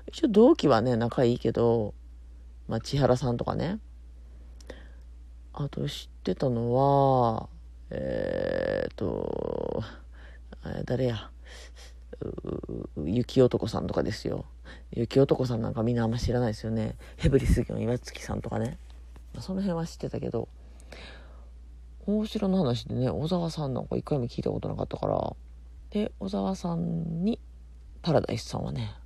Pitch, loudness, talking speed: 115 Hz, -28 LUFS, 280 characters per minute